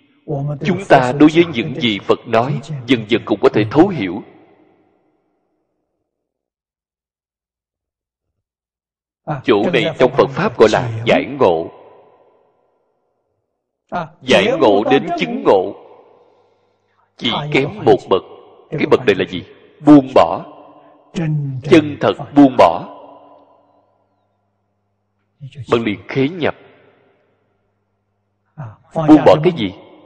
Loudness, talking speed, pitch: -15 LUFS, 105 wpm, 140 Hz